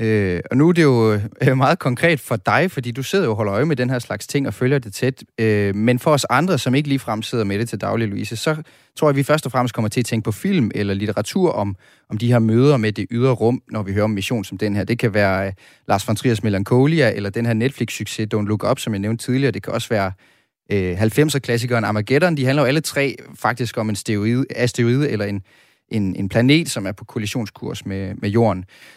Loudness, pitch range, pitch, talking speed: -19 LUFS, 105-130 Hz, 115 Hz, 250 wpm